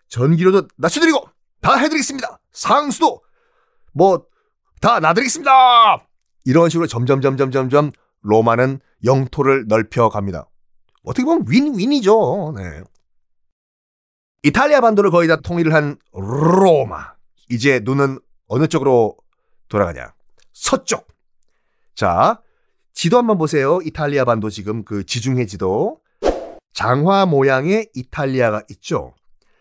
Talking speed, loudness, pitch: 255 characters per minute, -16 LUFS, 145 Hz